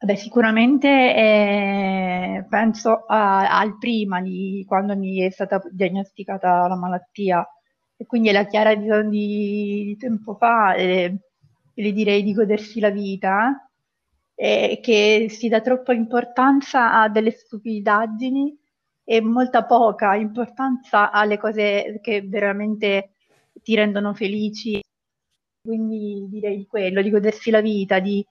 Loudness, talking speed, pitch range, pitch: -20 LUFS, 125 wpm, 200-225 Hz, 210 Hz